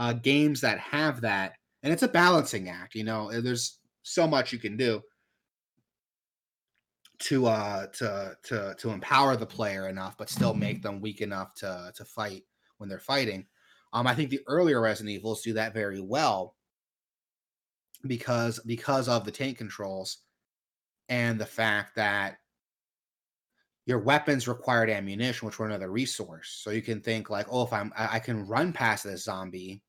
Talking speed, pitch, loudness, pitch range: 170 wpm, 110 Hz, -29 LUFS, 100-125 Hz